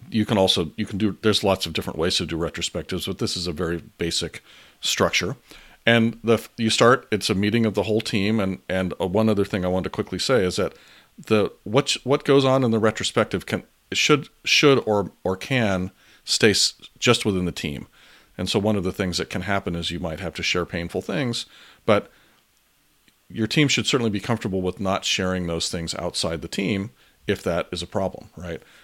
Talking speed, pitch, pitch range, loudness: 210 wpm, 100 Hz, 90-110 Hz, -22 LUFS